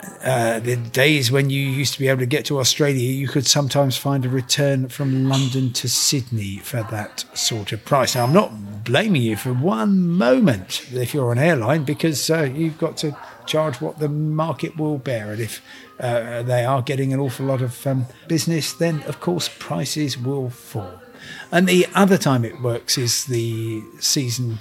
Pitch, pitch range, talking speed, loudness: 135 Hz, 120-150 Hz, 190 wpm, -20 LUFS